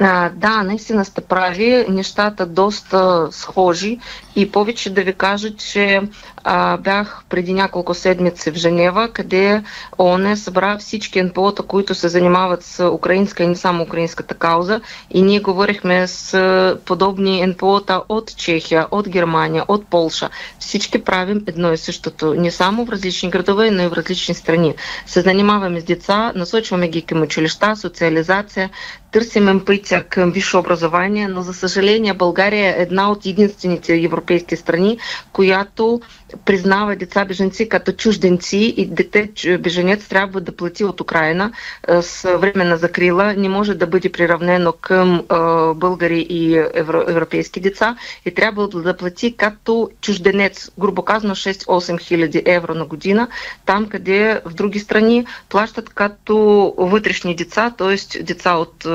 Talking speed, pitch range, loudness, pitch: 145 wpm, 175-205 Hz, -16 LUFS, 190 Hz